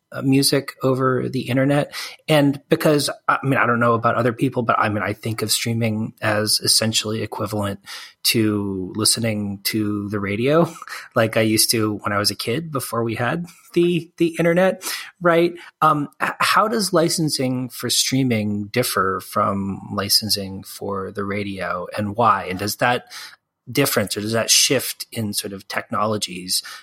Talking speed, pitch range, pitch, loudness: 160 wpm, 105-135 Hz, 115 Hz, -20 LUFS